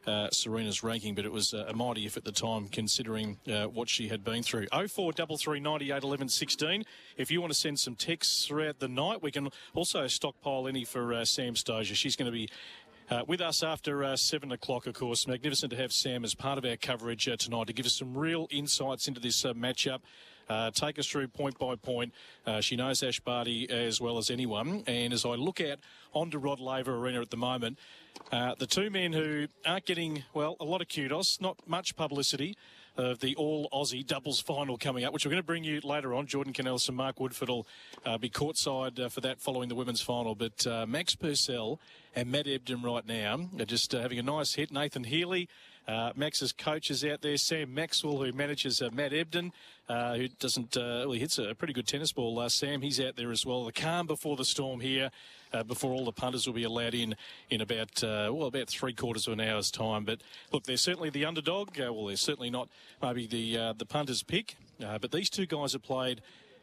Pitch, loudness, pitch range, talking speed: 130 Hz, -32 LUFS, 120-150 Hz, 230 wpm